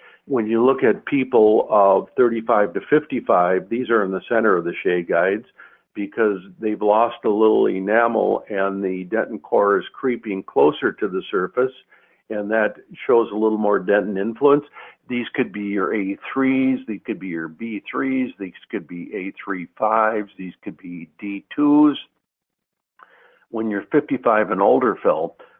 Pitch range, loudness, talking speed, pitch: 100-120 Hz, -20 LUFS, 155 wpm, 110 Hz